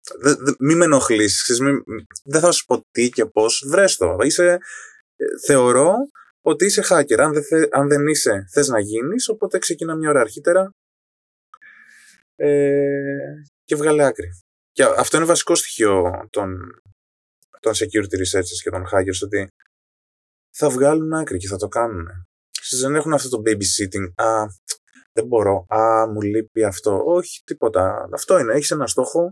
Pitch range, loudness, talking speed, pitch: 105-160 Hz, -18 LUFS, 165 wpm, 140 Hz